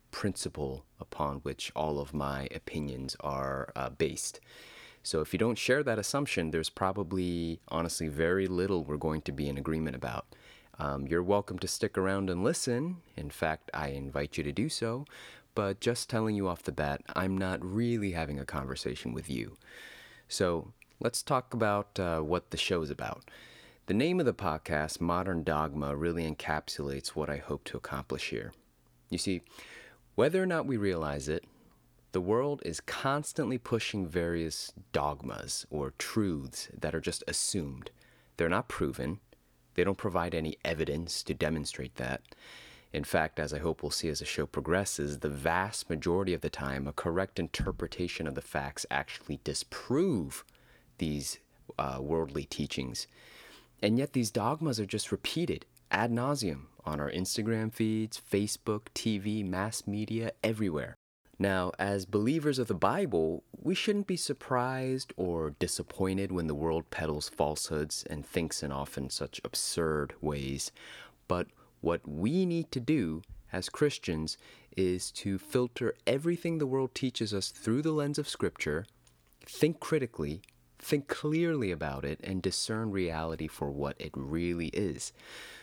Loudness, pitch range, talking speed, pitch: -33 LUFS, 75-110 Hz, 155 wpm, 90 Hz